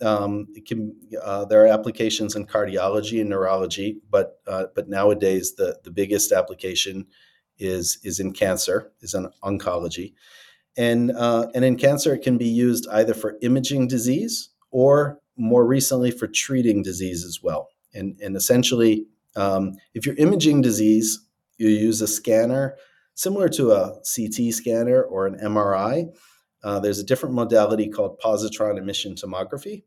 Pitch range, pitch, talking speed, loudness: 100-125 Hz, 110 Hz, 155 wpm, -22 LUFS